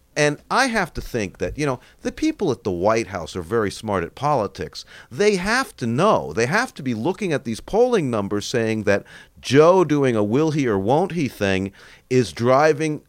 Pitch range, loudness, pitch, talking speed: 110-185 Hz, -21 LUFS, 130 Hz, 205 wpm